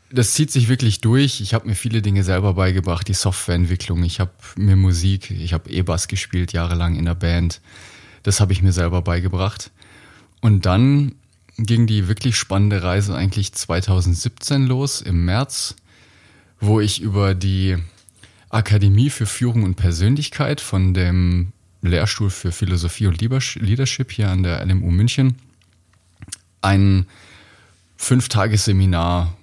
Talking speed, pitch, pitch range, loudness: 140 wpm, 100 Hz, 90-110 Hz, -19 LUFS